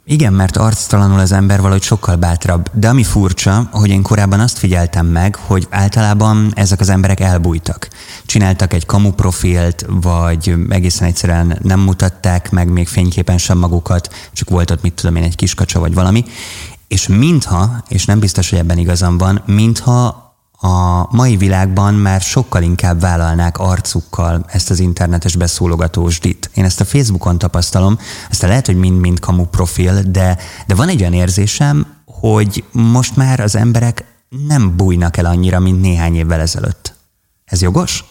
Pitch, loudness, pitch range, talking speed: 95 Hz, -12 LUFS, 90-105 Hz, 160 wpm